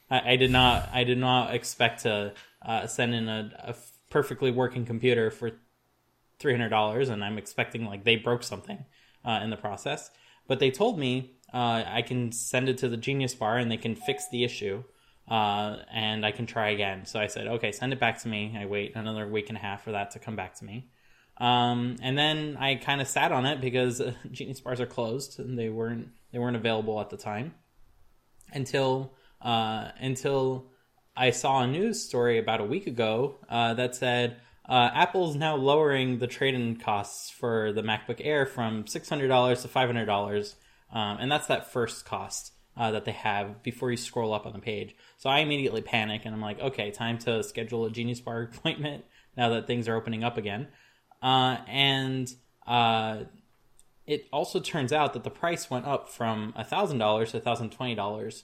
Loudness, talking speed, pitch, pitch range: -28 LUFS, 195 wpm, 120 Hz, 110-130 Hz